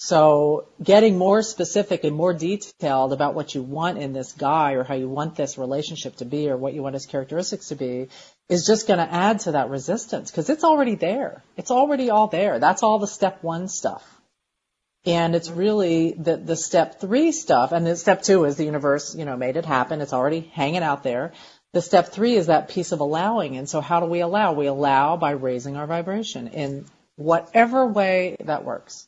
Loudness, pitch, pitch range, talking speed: -22 LUFS, 165 Hz, 145-195 Hz, 210 wpm